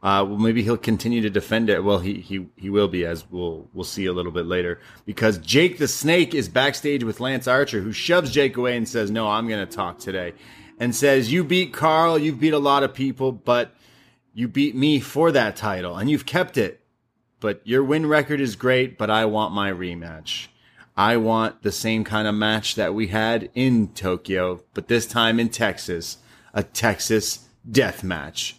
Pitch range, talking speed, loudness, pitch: 105-135 Hz, 205 wpm, -22 LUFS, 115 Hz